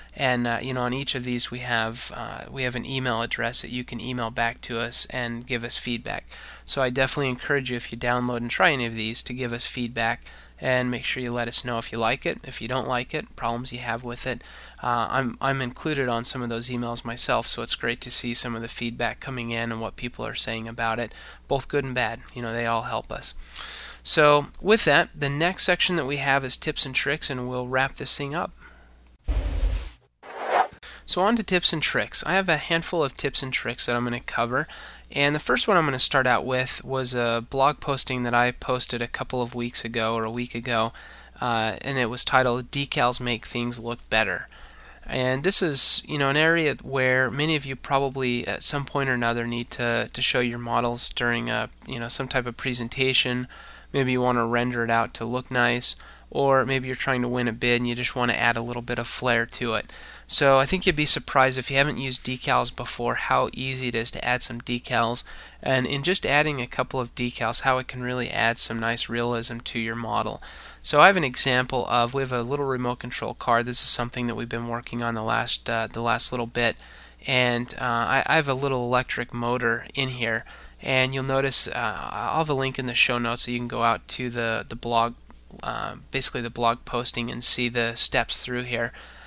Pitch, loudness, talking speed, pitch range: 125 Hz, -24 LUFS, 235 wpm, 115-130 Hz